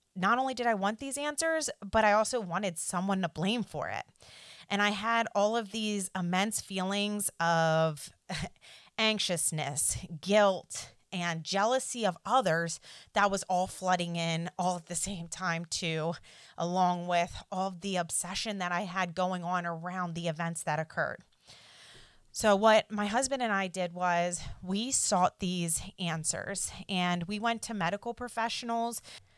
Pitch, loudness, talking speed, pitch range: 185 Hz, -31 LUFS, 155 wpm, 170-210 Hz